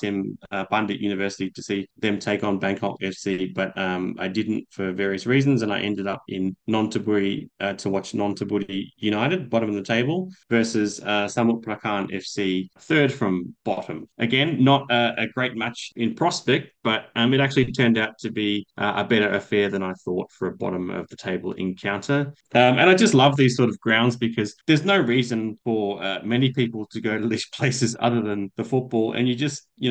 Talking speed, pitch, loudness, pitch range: 205 wpm, 110 Hz, -23 LUFS, 100-125 Hz